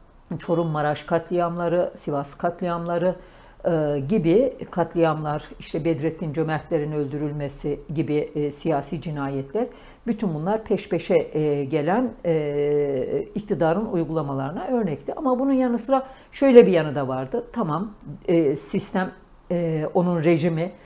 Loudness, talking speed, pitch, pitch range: -23 LUFS, 120 wpm, 170 Hz, 150-200 Hz